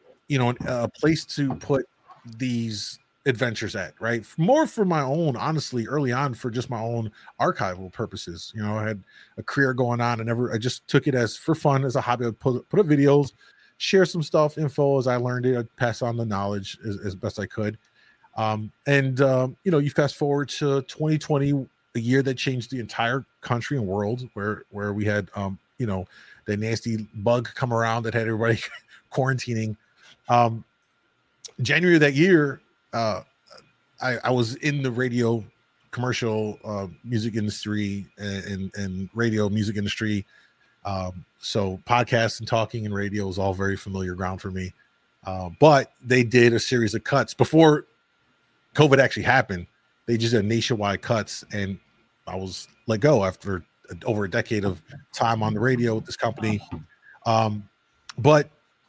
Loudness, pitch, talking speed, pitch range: -24 LUFS, 115 Hz, 175 wpm, 105-135 Hz